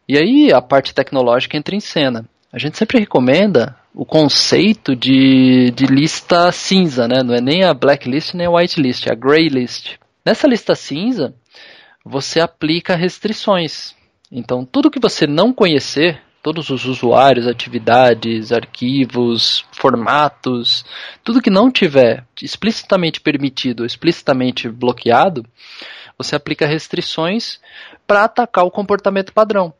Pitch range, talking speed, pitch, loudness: 130-190 Hz, 135 wpm, 150 Hz, -14 LUFS